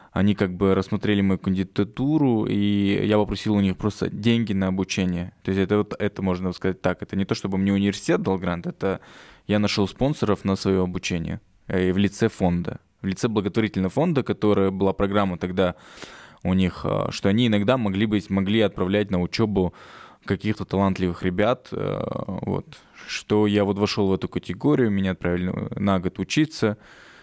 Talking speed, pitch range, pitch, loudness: 170 wpm, 95-105 Hz, 100 Hz, -23 LUFS